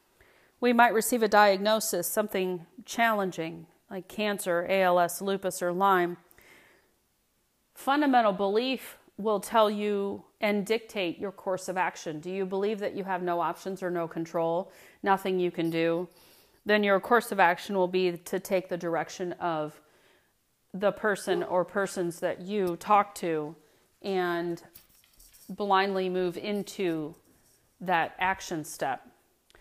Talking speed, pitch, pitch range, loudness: 135 wpm, 190 Hz, 175-205 Hz, -28 LUFS